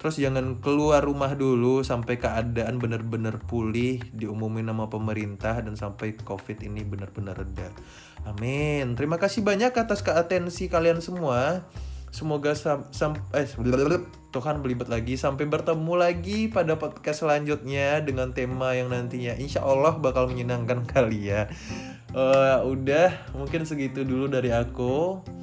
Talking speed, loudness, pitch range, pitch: 130 wpm, -26 LUFS, 115-150 Hz, 130 Hz